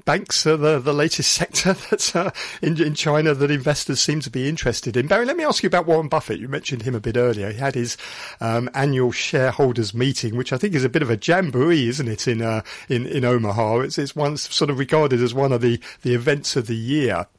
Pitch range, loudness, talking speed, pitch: 120-155 Hz, -20 LUFS, 240 wpm, 135 Hz